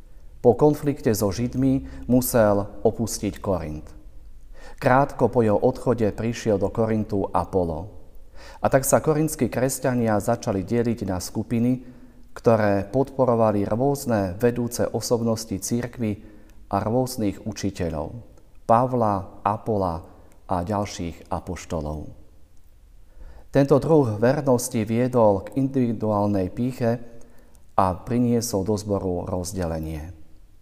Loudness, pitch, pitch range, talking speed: -23 LUFS, 105 Hz, 95-120 Hz, 100 wpm